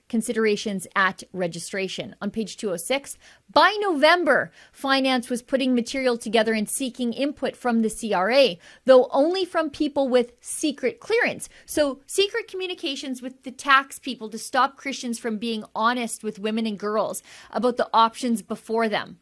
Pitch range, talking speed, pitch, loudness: 220-275 Hz, 150 wpm, 245 Hz, -23 LUFS